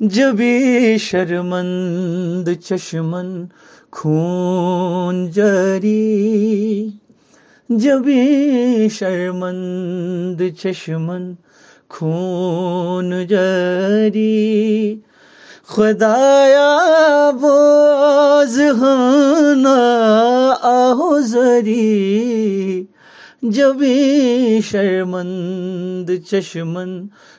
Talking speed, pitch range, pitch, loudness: 35 wpm, 180-250 Hz, 210 Hz, -15 LUFS